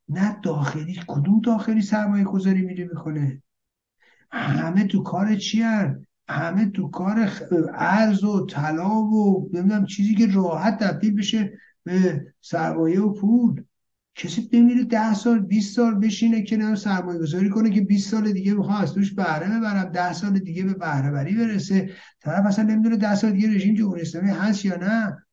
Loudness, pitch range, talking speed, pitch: -22 LUFS, 180-215 Hz, 165 wpm, 200 Hz